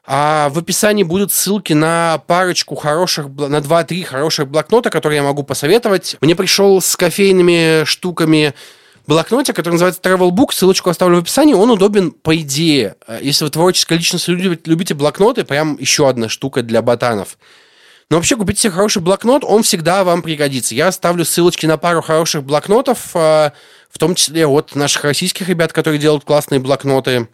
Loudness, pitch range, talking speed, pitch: -13 LUFS, 150-185 Hz, 160 wpm, 165 Hz